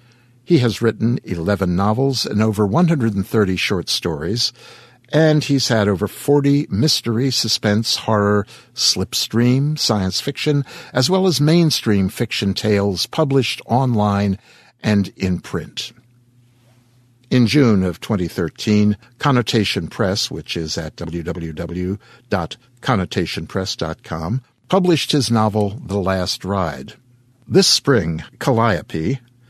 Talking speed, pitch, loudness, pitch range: 105 wpm, 115 Hz, -18 LUFS, 100-125 Hz